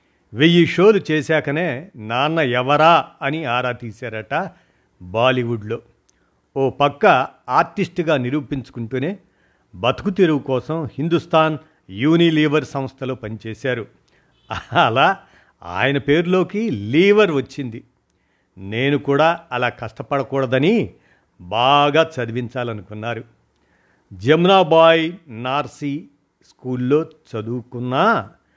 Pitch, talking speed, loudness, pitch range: 140 Hz, 70 wpm, -18 LUFS, 120-160 Hz